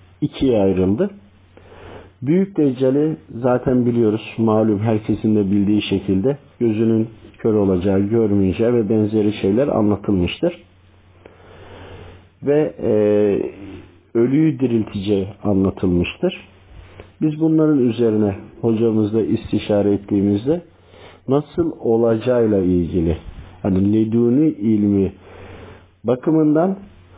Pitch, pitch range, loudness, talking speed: 105 Hz, 95-115 Hz, -18 LUFS, 80 wpm